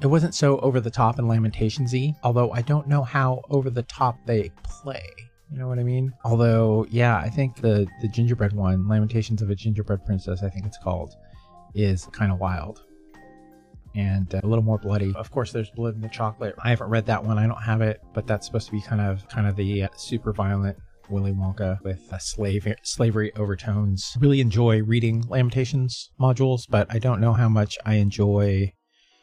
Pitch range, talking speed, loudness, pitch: 100-120 Hz, 205 wpm, -24 LUFS, 110 Hz